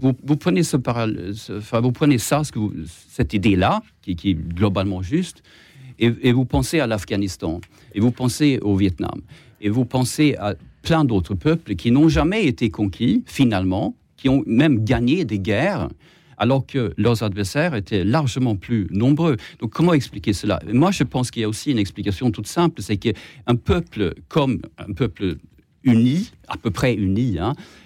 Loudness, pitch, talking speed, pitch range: -20 LUFS, 120 Hz, 185 wpm, 105-140 Hz